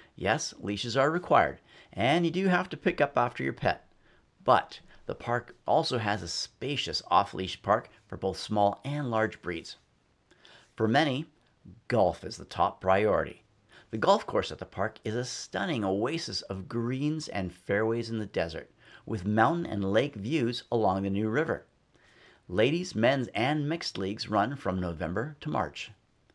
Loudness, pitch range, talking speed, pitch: -29 LUFS, 100-145 Hz, 165 wpm, 110 Hz